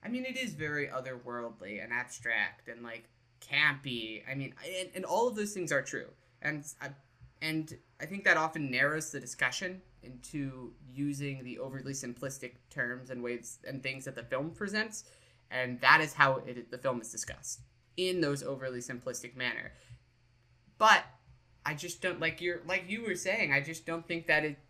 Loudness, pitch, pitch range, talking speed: -33 LUFS, 135 Hz, 125-160 Hz, 180 wpm